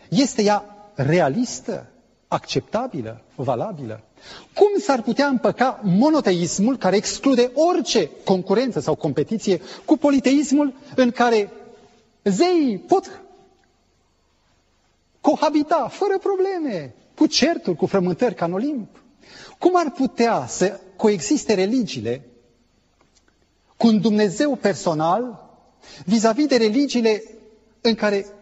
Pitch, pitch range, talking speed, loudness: 230 Hz, 195-285 Hz, 100 wpm, -20 LUFS